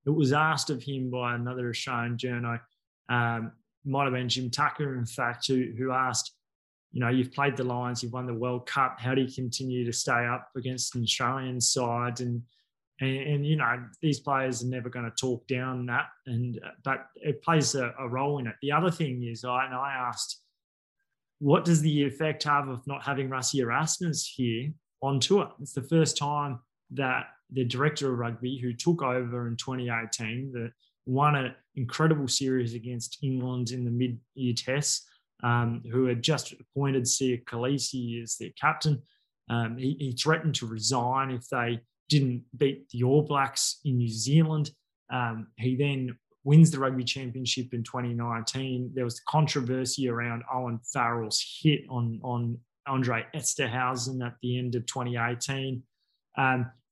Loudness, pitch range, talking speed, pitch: -29 LUFS, 120-140 Hz, 175 wpm, 130 Hz